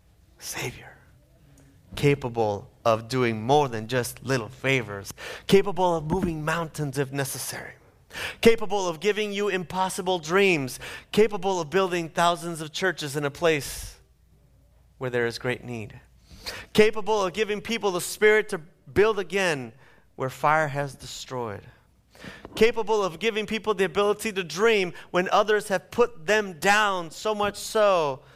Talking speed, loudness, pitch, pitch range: 140 wpm, -25 LUFS, 175 Hz, 135-205 Hz